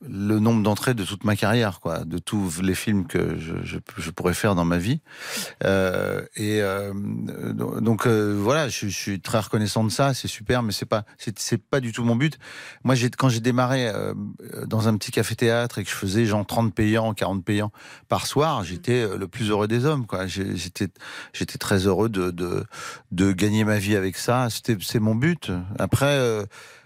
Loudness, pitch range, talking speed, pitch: -24 LUFS, 100-120 Hz, 210 wpm, 110 Hz